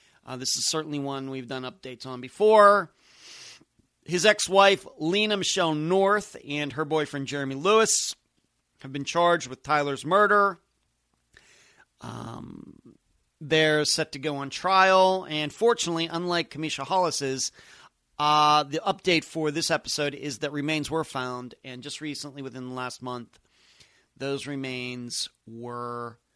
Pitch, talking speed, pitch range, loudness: 150 Hz, 135 wpm, 135-170 Hz, -25 LUFS